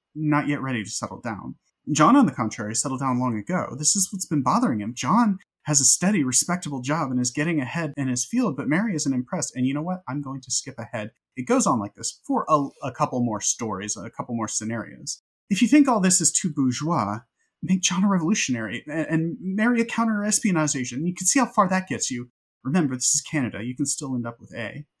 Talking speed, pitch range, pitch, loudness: 235 wpm, 125-185 Hz, 145 Hz, -23 LUFS